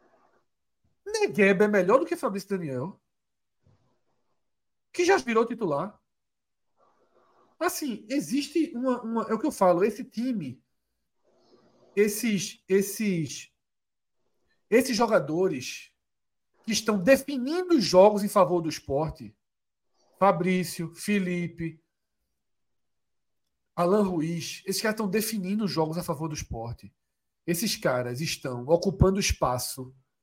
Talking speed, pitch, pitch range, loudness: 105 wpm, 195 Hz, 165-225 Hz, -26 LUFS